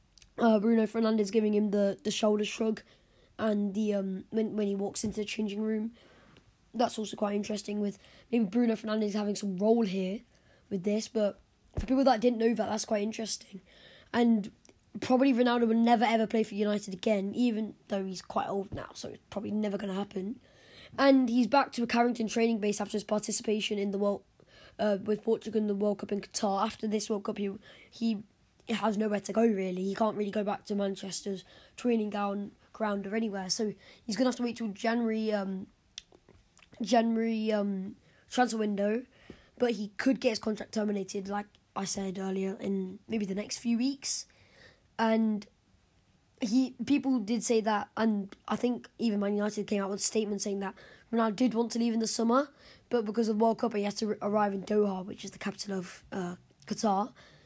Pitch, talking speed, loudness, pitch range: 215 Hz, 195 wpm, -31 LUFS, 205-230 Hz